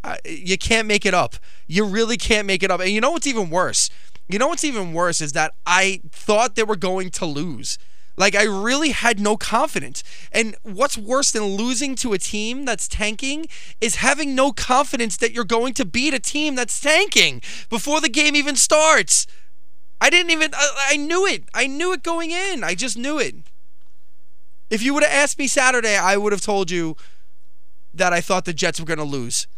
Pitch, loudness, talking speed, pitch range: 220 Hz, -19 LUFS, 210 wpm, 175-275 Hz